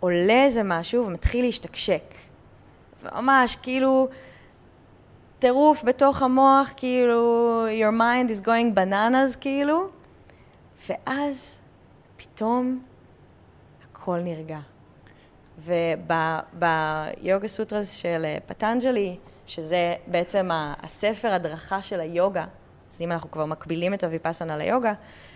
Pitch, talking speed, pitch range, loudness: 205 Hz, 90 wpm, 165-250 Hz, -23 LUFS